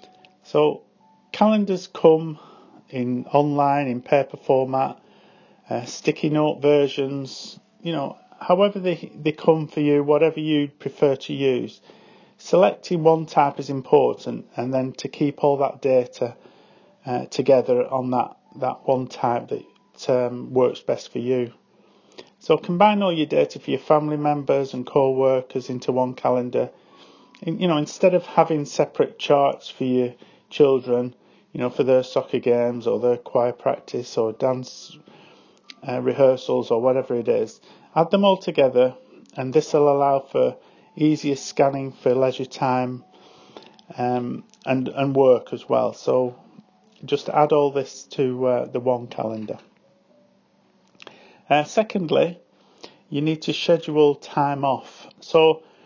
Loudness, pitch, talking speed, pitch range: -22 LUFS, 140 Hz, 140 wpm, 130-160 Hz